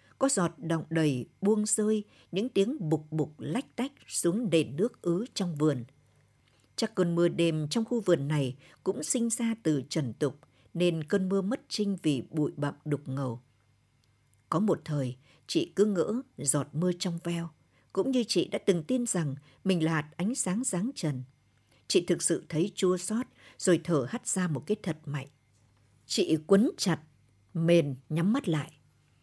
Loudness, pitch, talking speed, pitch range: -30 LUFS, 165 Hz, 180 wpm, 140-195 Hz